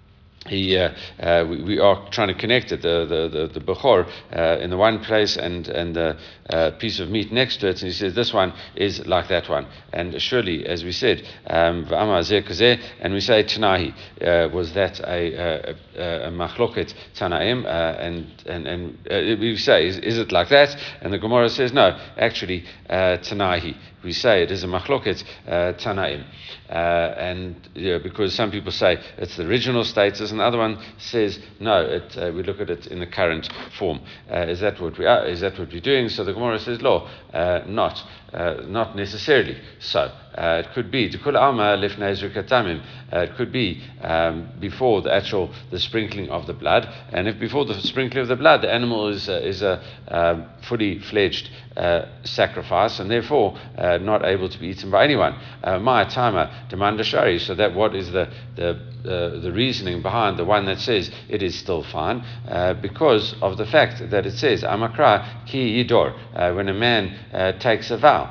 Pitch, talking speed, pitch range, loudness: 100 Hz, 190 wpm, 90-115 Hz, -21 LUFS